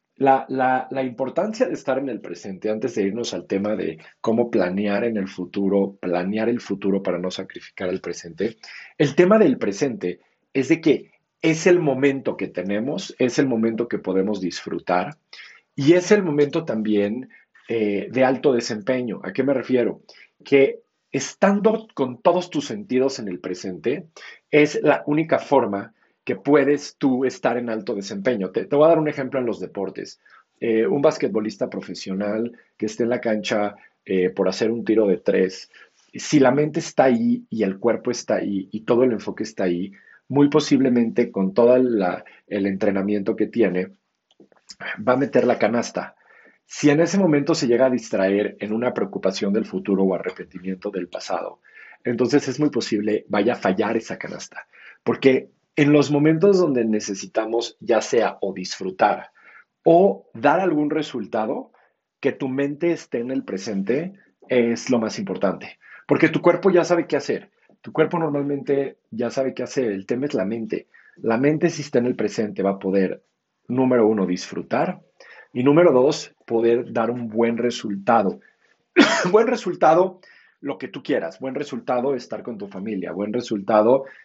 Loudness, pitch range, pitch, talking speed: -21 LUFS, 105-145 Hz, 120 Hz, 170 wpm